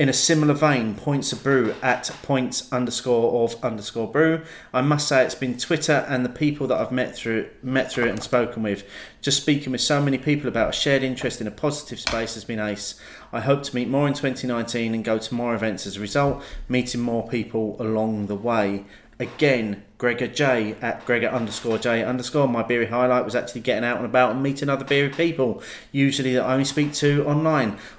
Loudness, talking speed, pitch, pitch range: -23 LUFS, 210 wpm, 125 Hz, 115-140 Hz